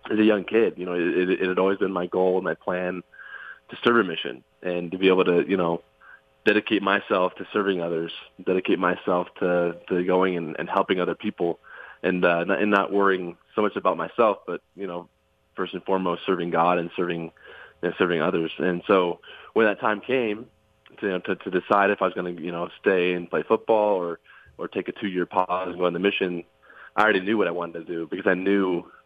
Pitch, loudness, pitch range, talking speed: 90 Hz, -24 LUFS, 85-100 Hz, 235 wpm